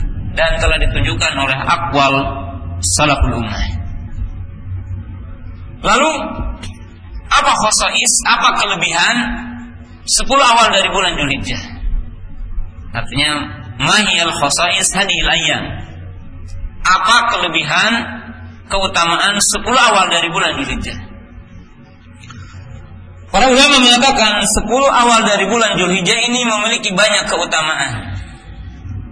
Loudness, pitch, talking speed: -12 LUFS, 110 Hz, 85 wpm